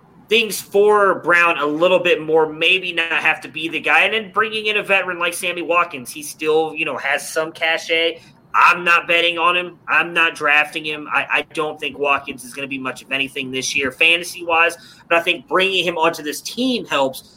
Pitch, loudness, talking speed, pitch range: 165 Hz, -17 LUFS, 220 wpm, 150-175 Hz